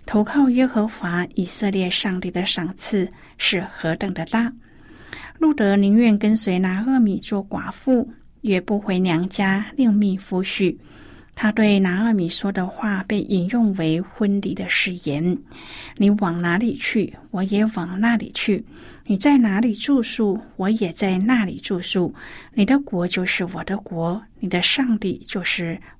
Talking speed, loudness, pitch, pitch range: 215 characters per minute, -21 LUFS, 200 Hz, 185-220 Hz